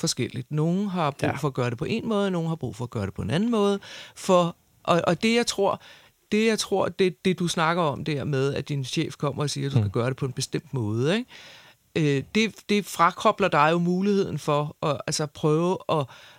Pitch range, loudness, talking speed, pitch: 140-190 Hz, -25 LUFS, 240 wpm, 160 Hz